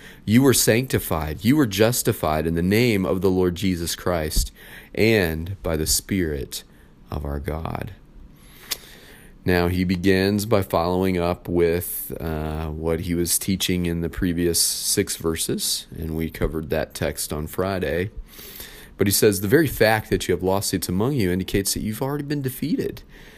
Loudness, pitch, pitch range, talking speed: -22 LUFS, 90 Hz, 80-100 Hz, 160 wpm